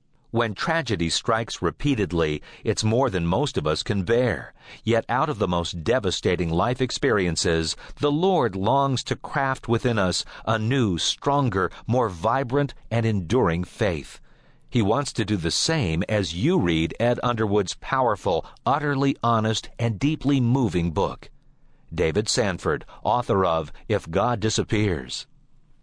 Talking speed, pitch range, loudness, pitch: 140 wpm, 90-130 Hz, -24 LUFS, 110 Hz